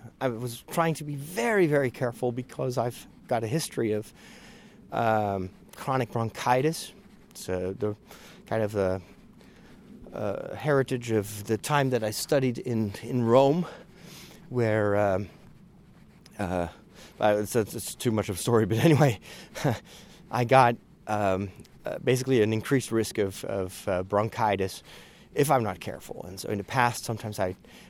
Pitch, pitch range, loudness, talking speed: 115 Hz, 105-135 Hz, -27 LUFS, 150 wpm